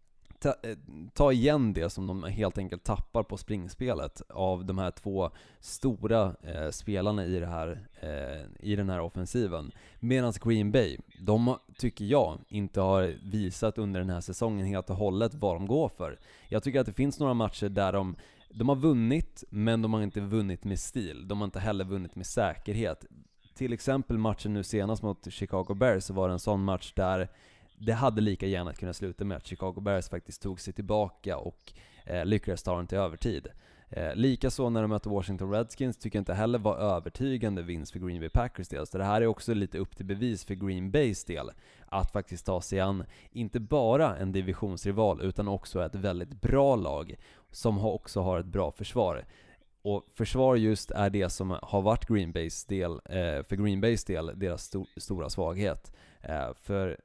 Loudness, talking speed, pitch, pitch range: -31 LUFS, 195 wpm, 100 Hz, 95-110 Hz